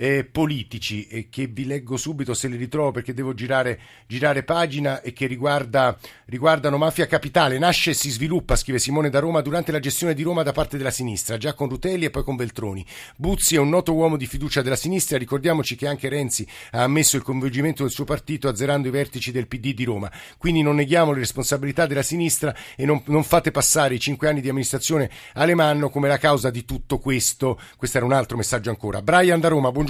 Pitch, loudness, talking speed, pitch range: 140 Hz, -22 LUFS, 210 wpm, 130-155 Hz